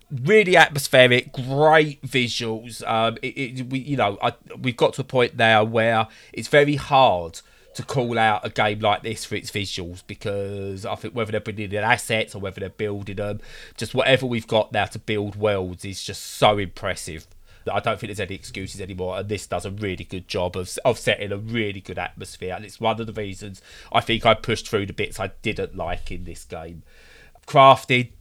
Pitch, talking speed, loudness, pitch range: 110 Hz, 210 wpm, -22 LUFS, 95-125 Hz